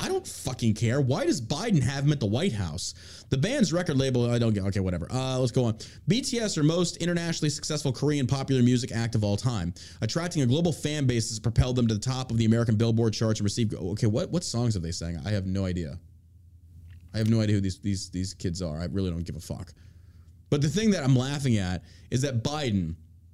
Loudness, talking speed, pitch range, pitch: -27 LUFS, 240 wpm, 95-135 Hz, 115 Hz